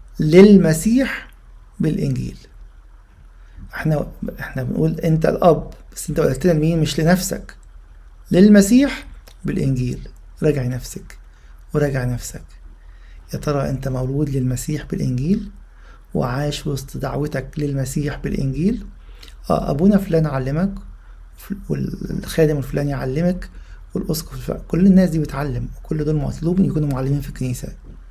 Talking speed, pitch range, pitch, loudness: 105 wpm, 130-170 Hz, 145 Hz, -19 LUFS